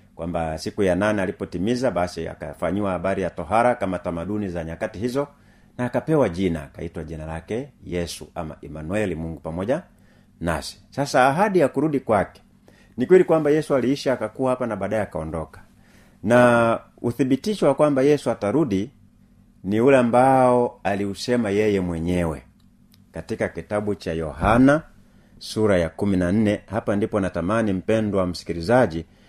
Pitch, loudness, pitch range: 105 Hz, -22 LUFS, 90-125 Hz